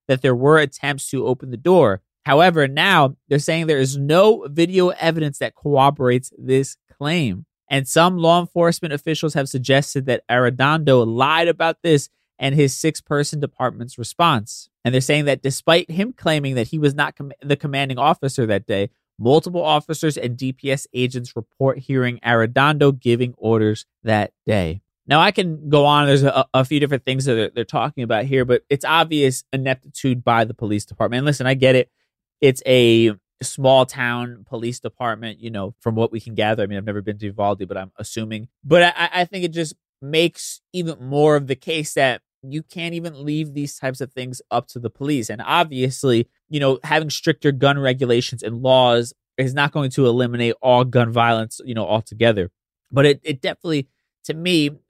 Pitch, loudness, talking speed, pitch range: 135 Hz, -19 LUFS, 190 wpm, 120-150 Hz